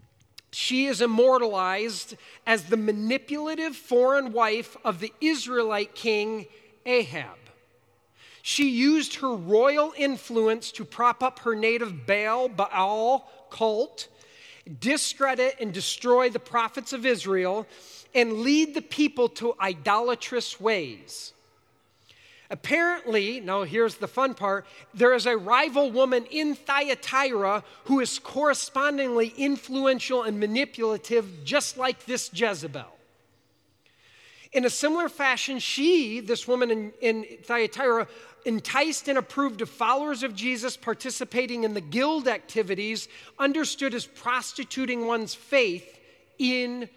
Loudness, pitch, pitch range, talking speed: -25 LUFS, 245 Hz, 220-270 Hz, 115 wpm